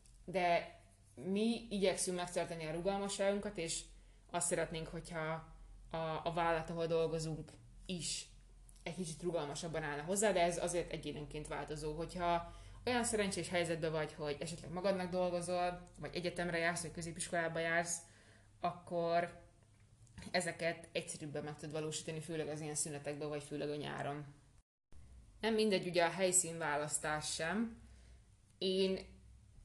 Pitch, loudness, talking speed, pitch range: 165 Hz, -39 LUFS, 125 wpm, 150-175 Hz